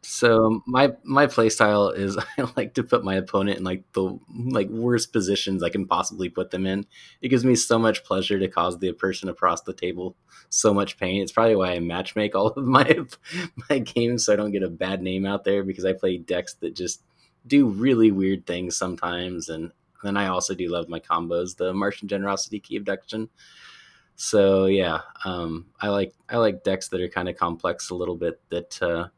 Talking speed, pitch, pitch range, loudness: 210 wpm, 95 Hz, 90-110 Hz, -24 LUFS